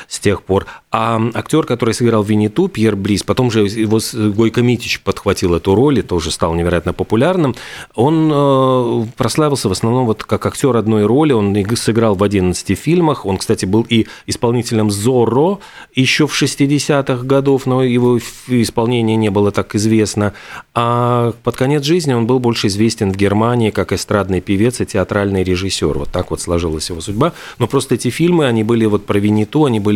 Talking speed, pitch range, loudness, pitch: 175 wpm, 100-125 Hz, -15 LUFS, 110 Hz